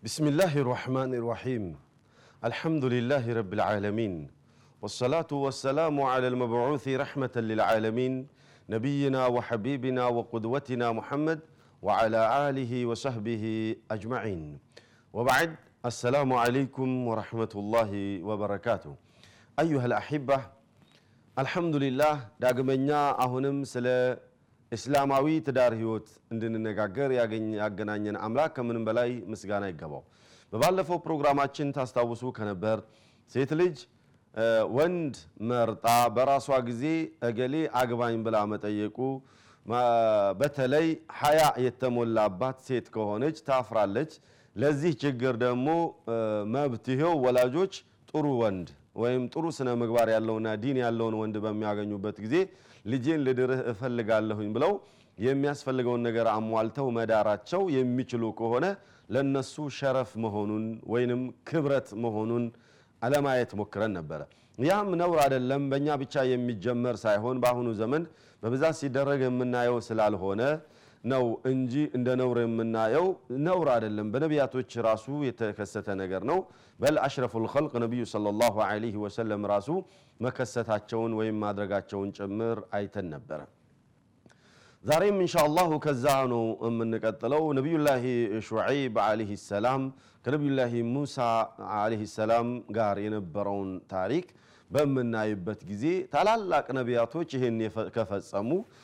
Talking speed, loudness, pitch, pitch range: 100 wpm, -29 LUFS, 120 Hz, 110-135 Hz